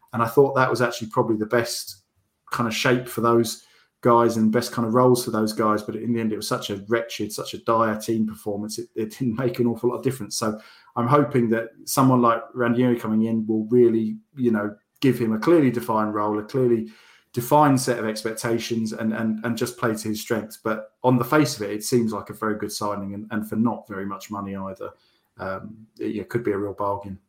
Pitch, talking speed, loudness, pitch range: 115 Hz, 235 wpm, -23 LUFS, 110-120 Hz